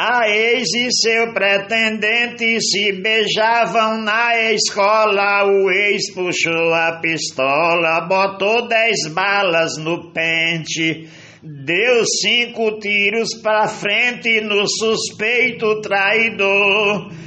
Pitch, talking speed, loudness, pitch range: 205 Hz, 95 wpm, -15 LUFS, 175-225 Hz